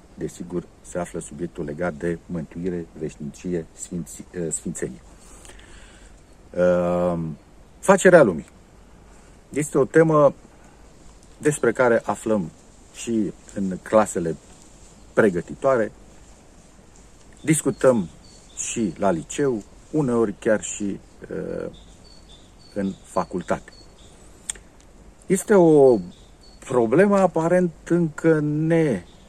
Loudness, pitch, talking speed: -22 LUFS, 105 Hz, 80 wpm